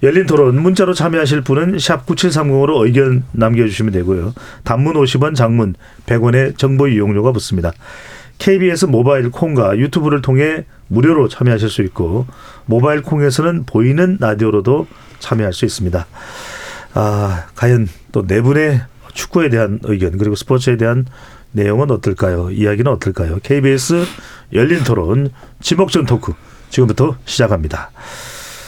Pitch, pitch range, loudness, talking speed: 125 Hz, 110-145 Hz, -14 LUFS, 310 characters per minute